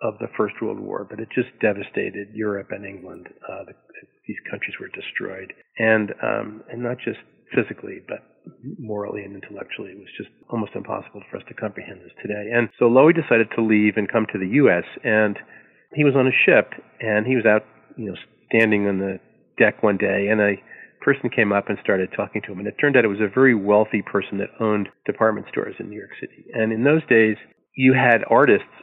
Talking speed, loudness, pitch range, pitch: 215 wpm, -20 LUFS, 105-120 Hz, 110 Hz